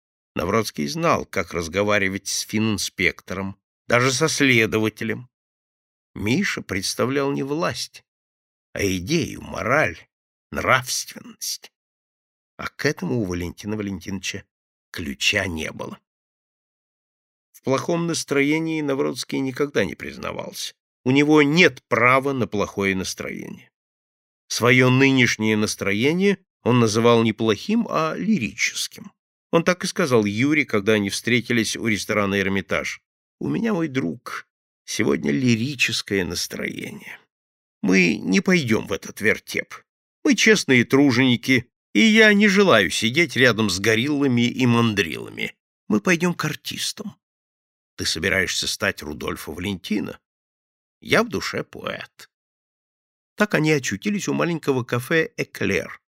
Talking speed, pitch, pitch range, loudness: 115 wpm, 120 Hz, 105-150 Hz, -21 LUFS